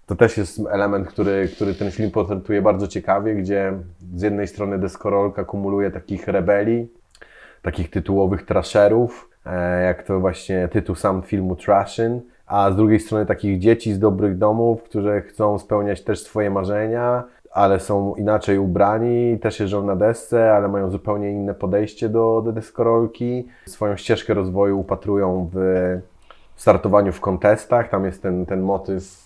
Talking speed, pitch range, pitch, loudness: 150 wpm, 95-110 Hz, 100 Hz, -20 LUFS